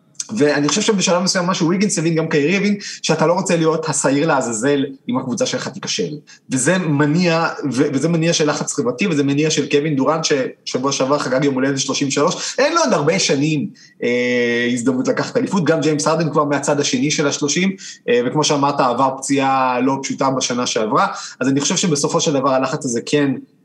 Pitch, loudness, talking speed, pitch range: 150 Hz, -17 LUFS, 190 wpm, 140-165 Hz